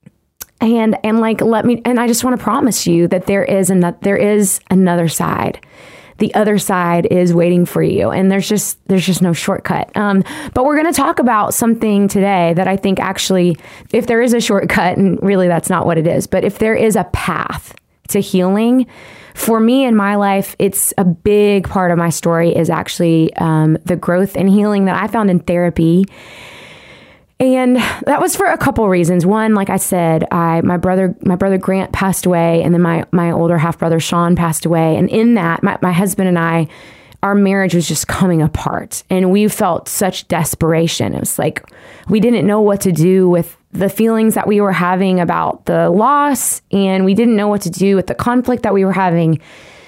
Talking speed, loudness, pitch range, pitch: 205 wpm, -14 LUFS, 175-210 Hz, 190 Hz